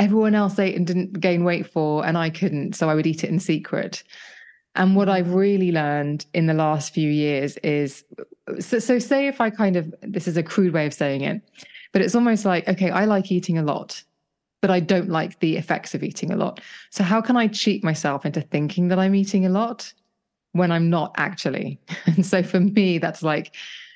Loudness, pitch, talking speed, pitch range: -22 LUFS, 180 Hz, 220 wpm, 160-205 Hz